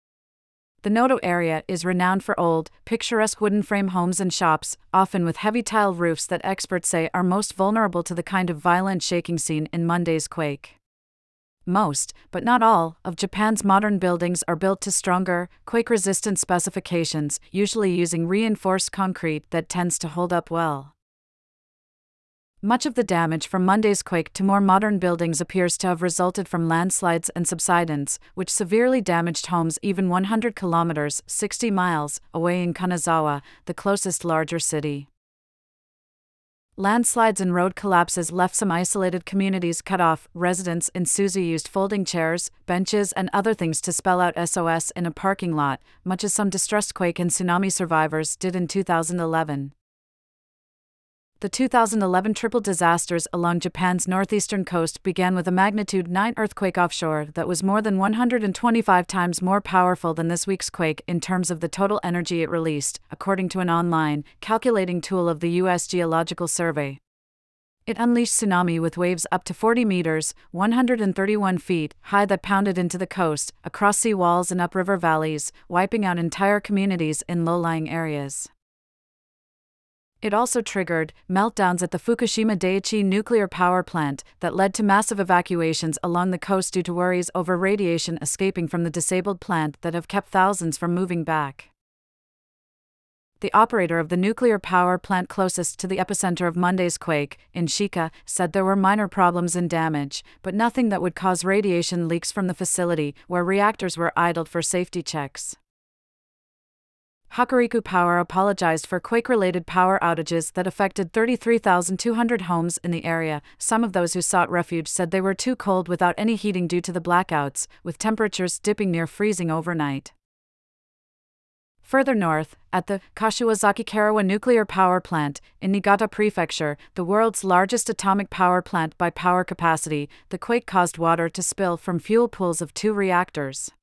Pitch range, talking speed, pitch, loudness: 170-200 Hz, 160 wpm, 180 Hz, -22 LUFS